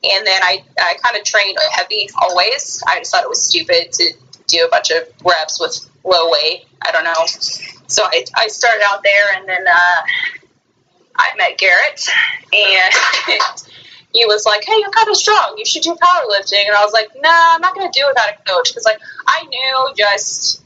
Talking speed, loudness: 210 wpm, -13 LUFS